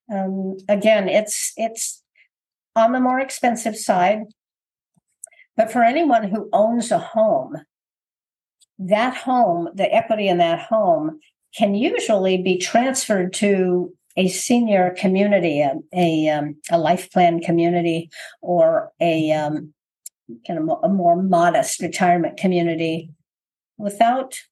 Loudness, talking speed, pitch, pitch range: -19 LUFS, 120 wpm, 205 Hz, 175-240 Hz